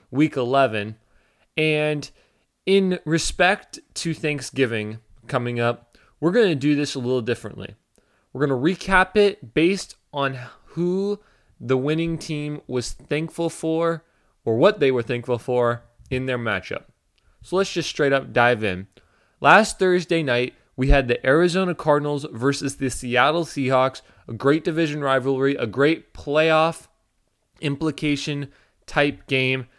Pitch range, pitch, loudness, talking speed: 125-160 Hz, 140 Hz, -22 LUFS, 140 wpm